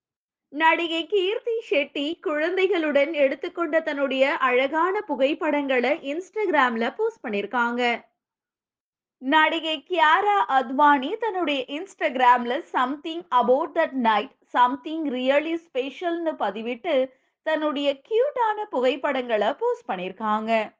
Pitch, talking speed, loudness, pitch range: 295 Hz, 85 wpm, -23 LUFS, 255-335 Hz